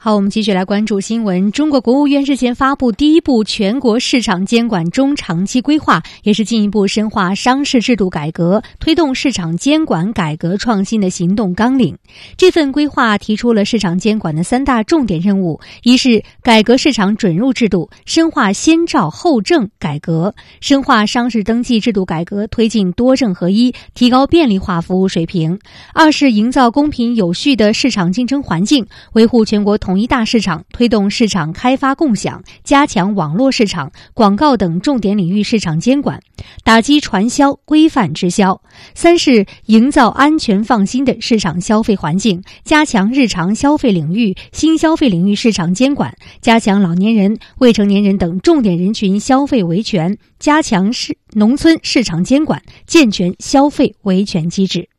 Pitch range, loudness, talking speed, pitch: 195-270 Hz, -13 LUFS, 270 characters per minute, 225 Hz